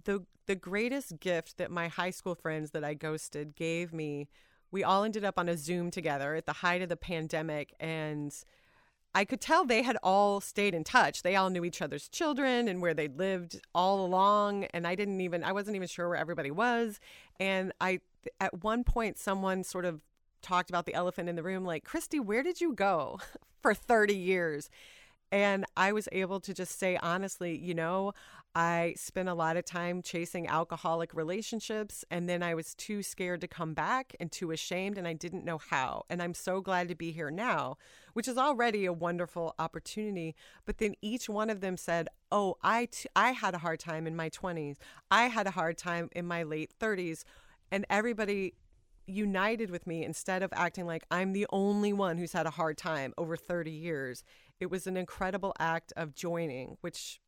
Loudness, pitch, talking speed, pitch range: -33 LUFS, 180 Hz, 200 wpm, 165-200 Hz